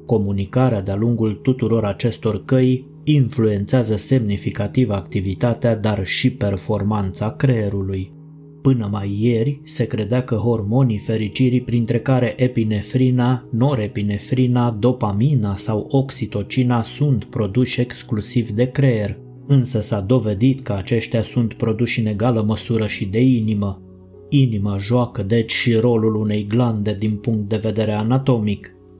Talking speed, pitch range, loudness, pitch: 120 wpm, 105-125 Hz, -19 LUFS, 115 Hz